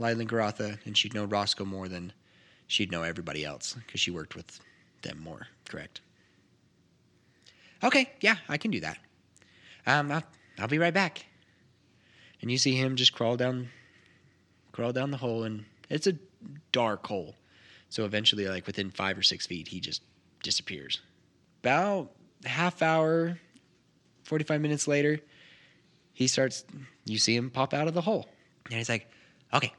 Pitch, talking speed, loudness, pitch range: 130 Hz, 160 wpm, -29 LUFS, 110-155 Hz